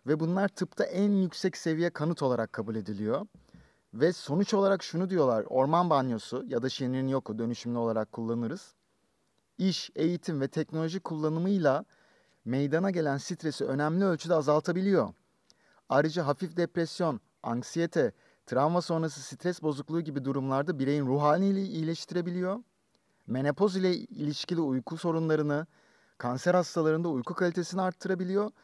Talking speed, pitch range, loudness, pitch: 120 wpm, 140-180 Hz, -30 LUFS, 160 Hz